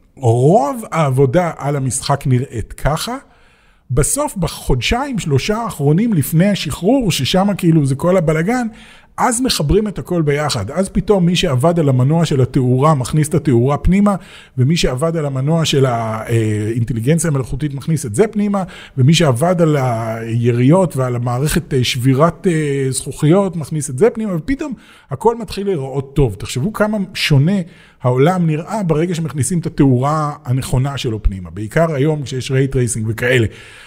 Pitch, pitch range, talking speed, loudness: 155 Hz, 130-185 Hz, 140 wpm, -16 LUFS